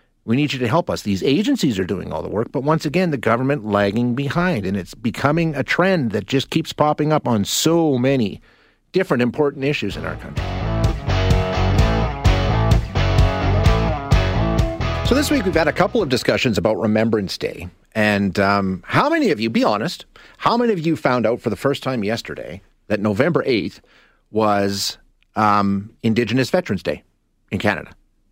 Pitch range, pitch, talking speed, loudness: 100-140 Hz, 110 Hz, 170 wpm, -19 LUFS